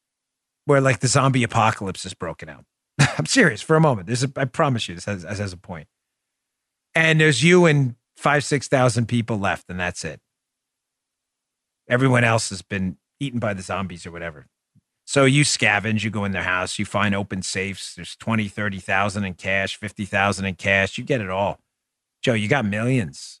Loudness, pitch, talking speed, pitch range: -21 LUFS, 105 Hz, 185 wpm, 95-130 Hz